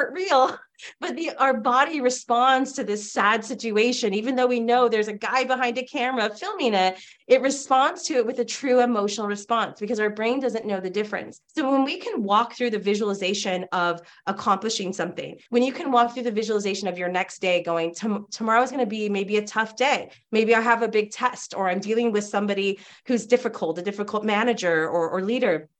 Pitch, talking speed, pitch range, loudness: 220 Hz, 210 wpm, 200-250 Hz, -23 LUFS